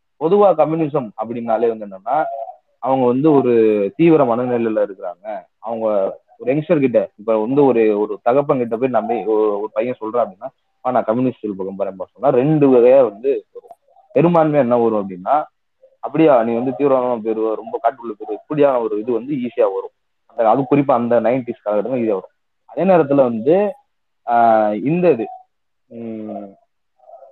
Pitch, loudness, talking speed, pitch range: 125 Hz, -17 LUFS, 145 wpm, 110-165 Hz